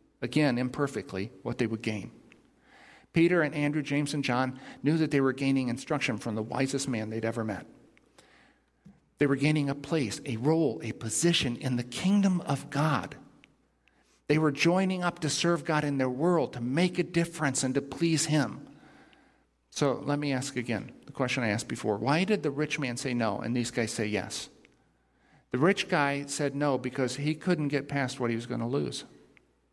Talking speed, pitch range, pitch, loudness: 190 wpm, 120-150 Hz, 140 Hz, -29 LUFS